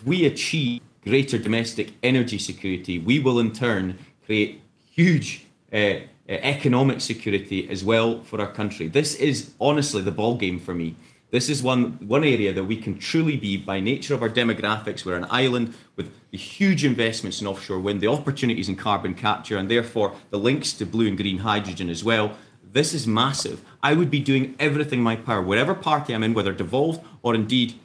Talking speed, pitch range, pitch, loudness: 190 wpm, 100-135 Hz, 115 Hz, -23 LUFS